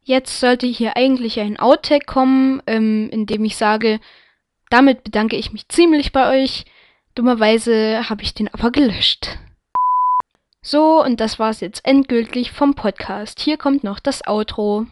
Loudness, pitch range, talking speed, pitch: -17 LUFS, 215-270 Hz, 155 wpm, 235 Hz